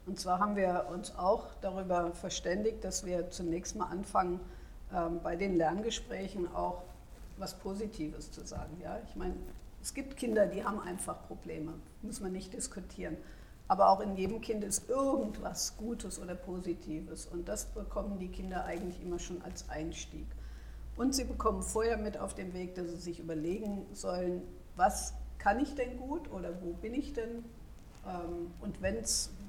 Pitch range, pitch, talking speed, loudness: 170-210 Hz, 185 Hz, 170 wpm, -36 LUFS